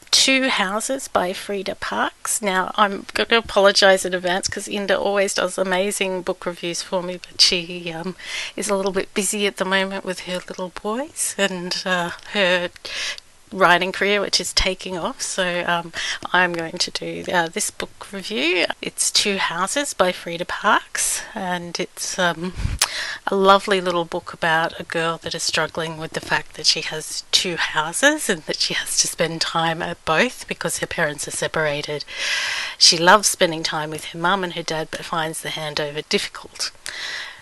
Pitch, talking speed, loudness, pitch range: 185 Hz, 180 wpm, -20 LUFS, 170-200 Hz